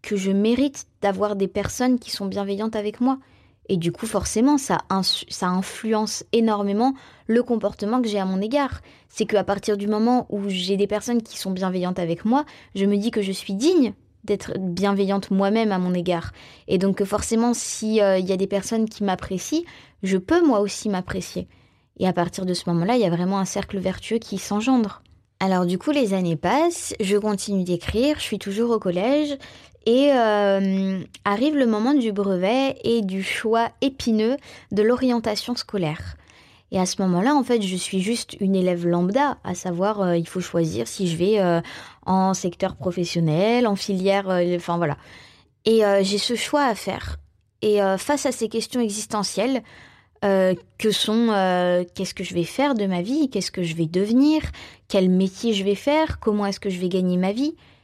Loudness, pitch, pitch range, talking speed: -22 LUFS, 200 Hz, 185-230 Hz, 195 wpm